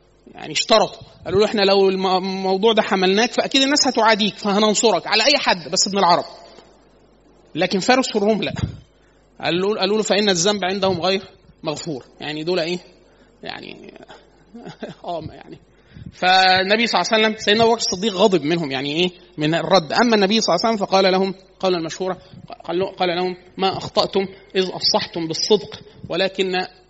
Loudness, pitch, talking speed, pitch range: -18 LUFS, 190 Hz, 155 wpm, 180-215 Hz